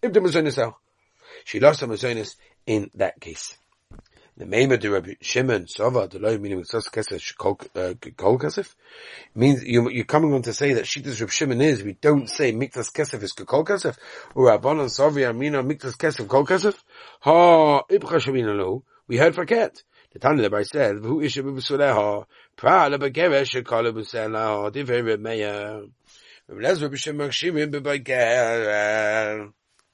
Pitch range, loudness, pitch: 110-145 Hz, -22 LUFS, 135 Hz